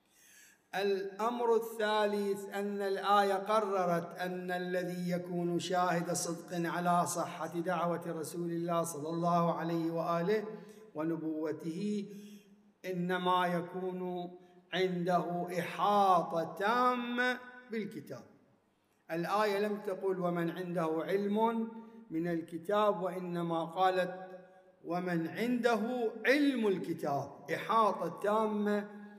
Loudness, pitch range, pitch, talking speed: -34 LUFS, 170-205 Hz, 180 Hz, 85 wpm